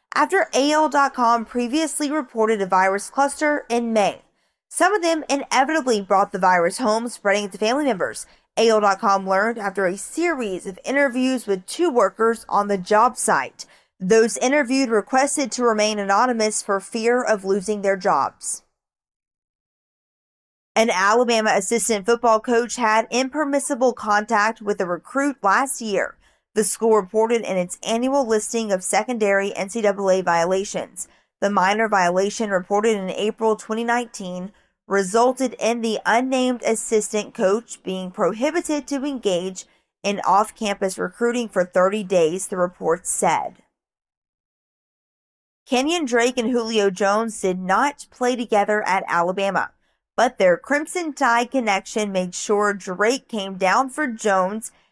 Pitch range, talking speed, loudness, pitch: 195-245 Hz, 135 wpm, -20 LUFS, 220 Hz